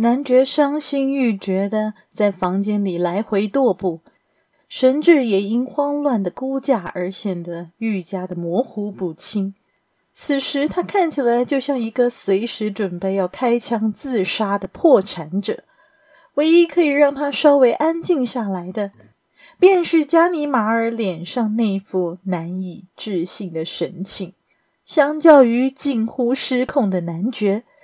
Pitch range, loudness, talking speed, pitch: 195-275 Hz, -19 LUFS, 210 characters per minute, 230 Hz